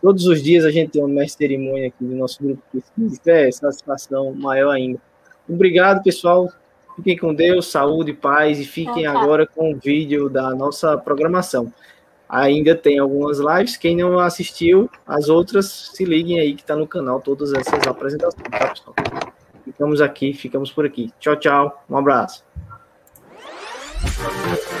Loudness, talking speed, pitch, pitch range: -18 LUFS, 150 wpm, 150 Hz, 140-175 Hz